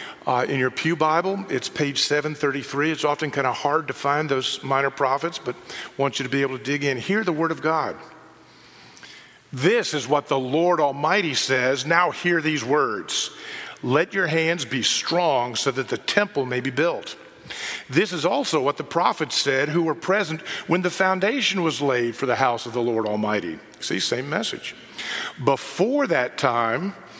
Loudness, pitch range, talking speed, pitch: -23 LUFS, 135-165 Hz, 190 wpm, 145 Hz